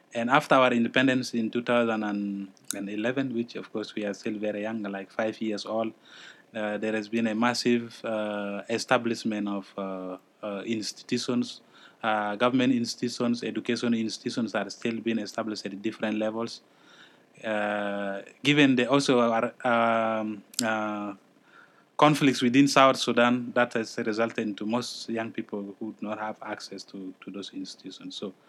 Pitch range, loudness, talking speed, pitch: 105-120 Hz, -27 LUFS, 150 wpm, 115 Hz